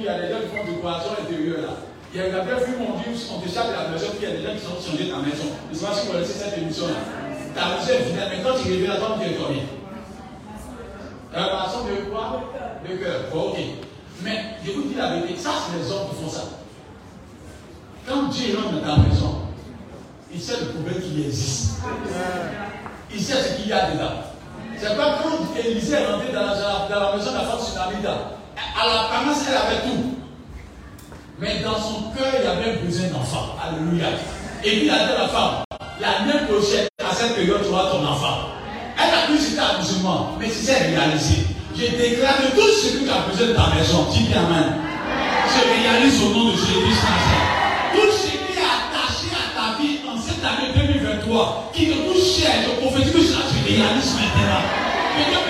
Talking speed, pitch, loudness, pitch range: 225 wpm, 210 Hz, -21 LUFS, 170-255 Hz